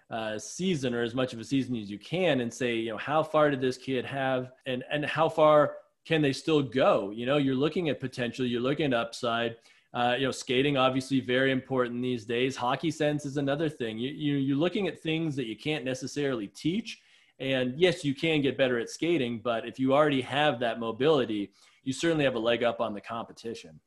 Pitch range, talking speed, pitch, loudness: 120-145 Hz, 220 wpm, 130 Hz, -28 LUFS